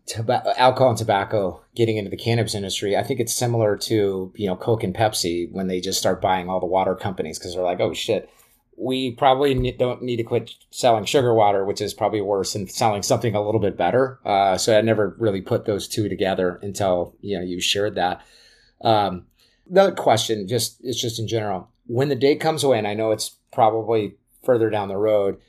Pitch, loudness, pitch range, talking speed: 110 Hz, -21 LUFS, 100-120 Hz, 210 wpm